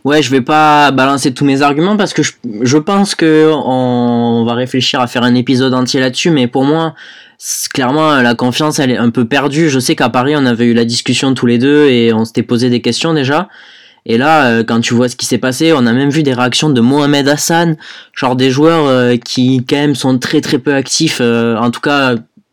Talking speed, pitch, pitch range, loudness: 230 wpm, 130 Hz, 125-150 Hz, -11 LUFS